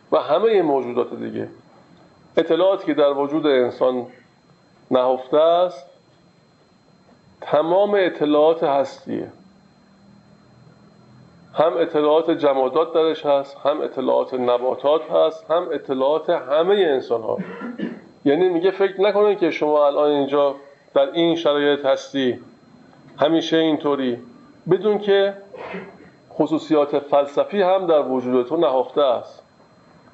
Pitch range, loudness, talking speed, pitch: 140-180 Hz, -19 LUFS, 105 wpm, 155 Hz